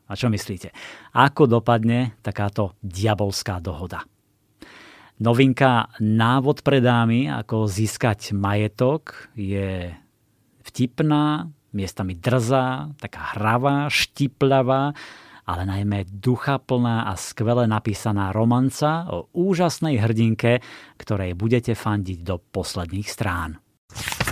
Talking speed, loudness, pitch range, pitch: 95 wpm, -22 LUFS, 100-130 Hz, 115 Hz